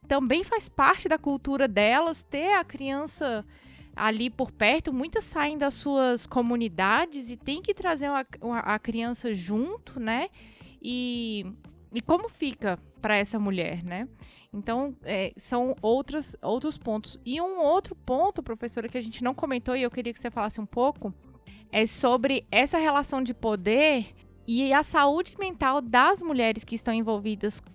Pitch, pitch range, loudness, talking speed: 250 Hz, 225-290 Hz, -27 LUFS, 160 wpm